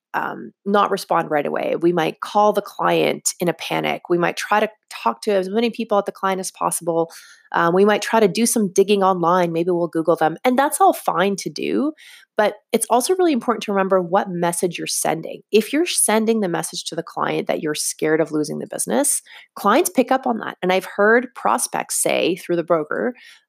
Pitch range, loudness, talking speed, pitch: 170-230 Hz, -19 LUFS, 215 wpm, 200 Hz